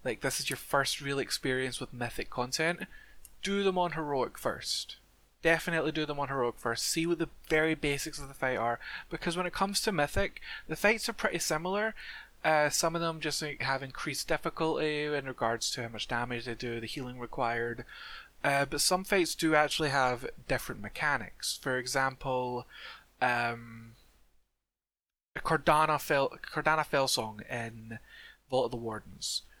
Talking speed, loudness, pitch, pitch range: 165 wpm, -31 LUFS, 140 Hz, 120-165 Hz